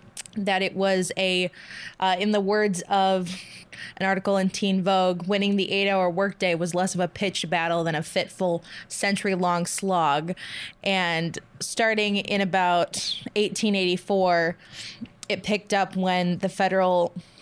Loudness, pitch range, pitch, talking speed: -24 LUFS, 180-200 Hz, 190 Hz, 140 wpm